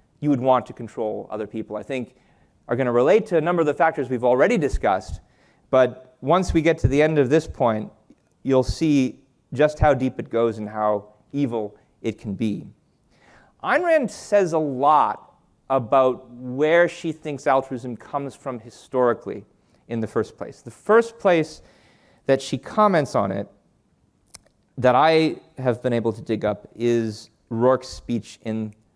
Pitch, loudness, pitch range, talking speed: 130 Hz, -22 LUFS, 115-150 Hz, 170 wpm